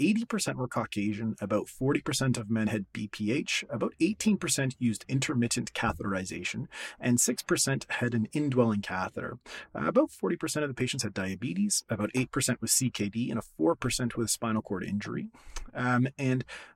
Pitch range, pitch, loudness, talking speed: 110-140 Hz, 125 Hz, -30 LUFS, 145 wpm